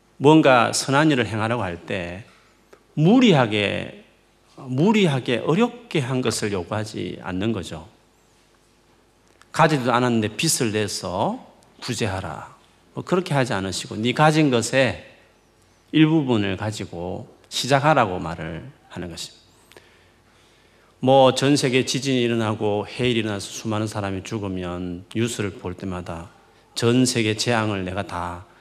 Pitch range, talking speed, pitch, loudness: 95-130 Hz, 265 characters per minute, 110 Hz, -21 LUFS